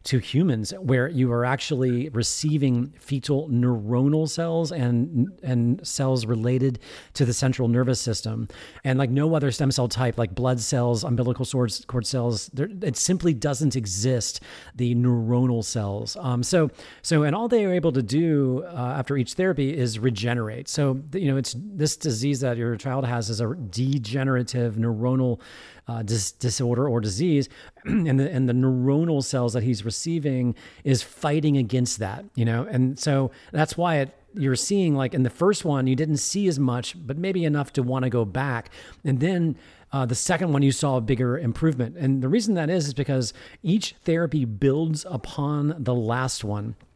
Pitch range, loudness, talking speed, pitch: 120-150 Hz, -24 LUFS, 180 wpm, 130 Hz